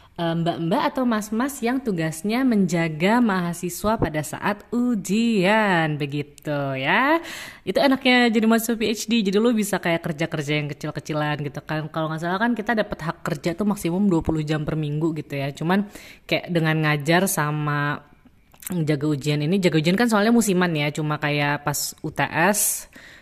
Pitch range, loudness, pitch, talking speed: 150-215 Hz, -22 LUFS, 170 Hz, 155 wpm